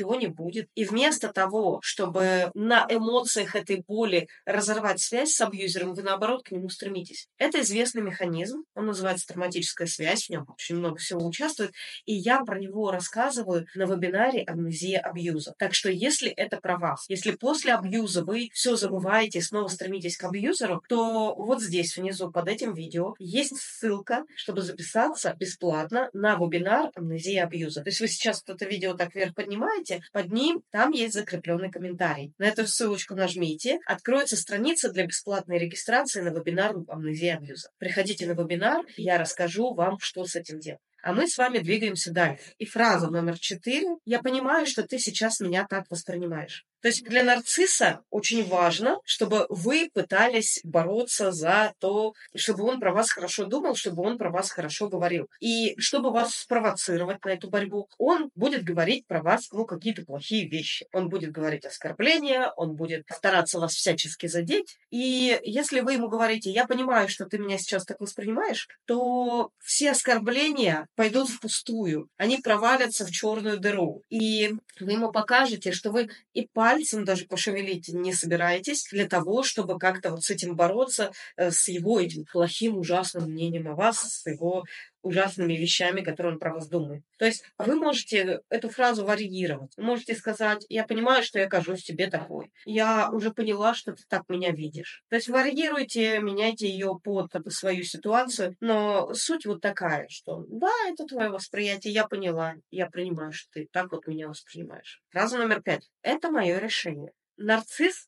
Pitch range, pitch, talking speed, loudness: 180-230 Hz, 200 Hz, 165 wpm, -27 LUFS